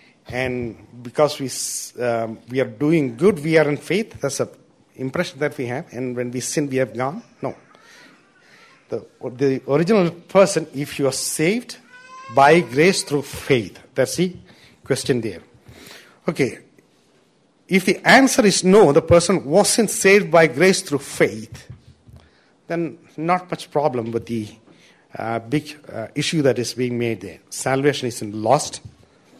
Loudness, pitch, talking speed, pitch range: -19 LUFS, 145 Hz, 150 wpm, 125-170 Hz